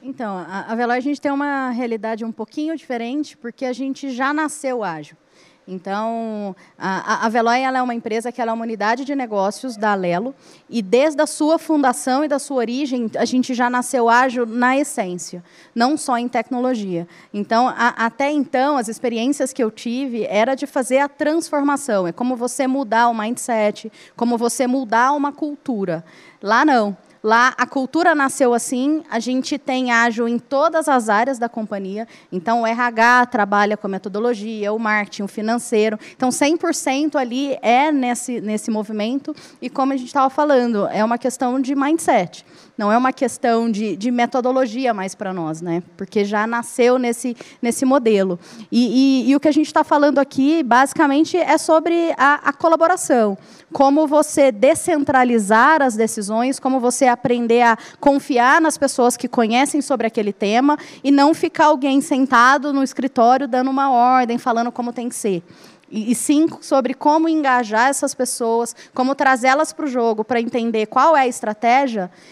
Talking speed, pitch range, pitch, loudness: 175 wpm, 225-275 Hz, 250 Hz, -18 LUFS